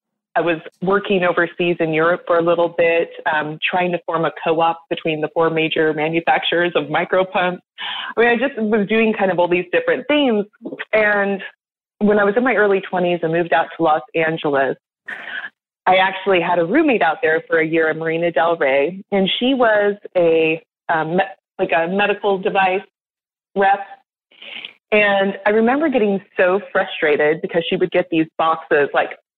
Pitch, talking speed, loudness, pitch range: 180 Hz, 180 wpm, -18 LUFS, 165-205 Hz